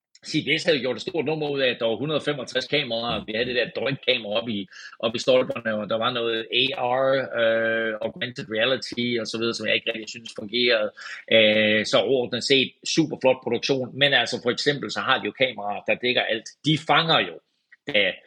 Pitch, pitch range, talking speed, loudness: 120 Hz, 115-140 Hz, 210 wpm, -23 LUFS